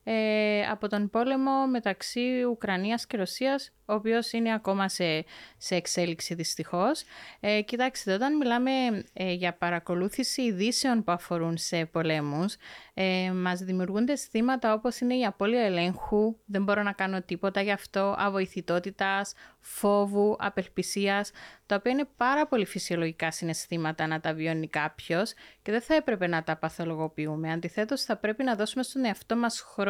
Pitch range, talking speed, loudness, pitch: 180-235 Hz, 150 wpm, -29 LUFS, 200 Hz